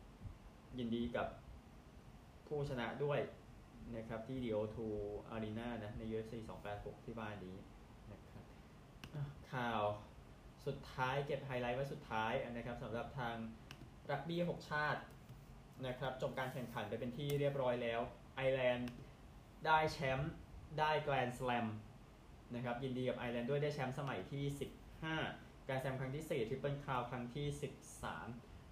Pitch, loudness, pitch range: 125 Hz, -43 LUFS, 115-140 Hz